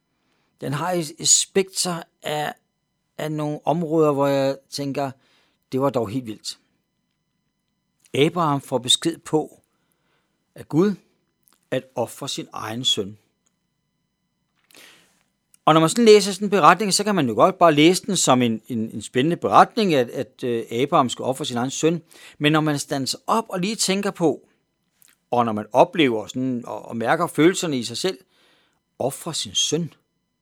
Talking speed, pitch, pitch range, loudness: 160 wpm, 150 Hz, 130-170 Hz, -21 LUFS